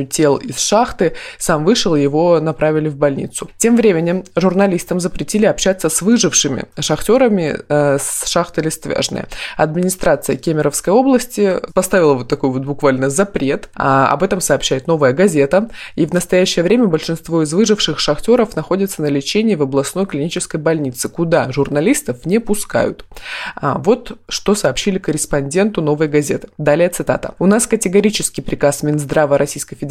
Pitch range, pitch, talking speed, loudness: 145-195 Hz, 165 Hz, 140 wpm, -15 LUFS